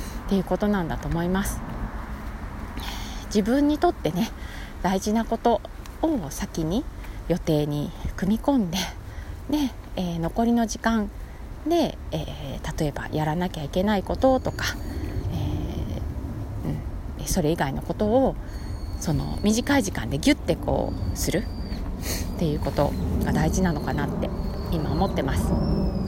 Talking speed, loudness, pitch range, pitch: 260 characters per minute, -26 LUFS, 145-235 Hz, 190 Hz